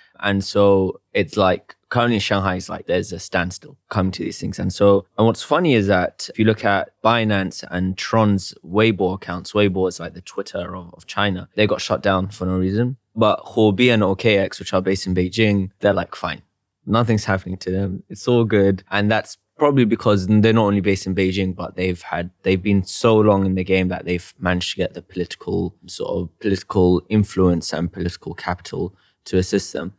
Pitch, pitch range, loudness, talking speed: 95 Hz, 90-105 Hz, -20 LUFS, 205 wpm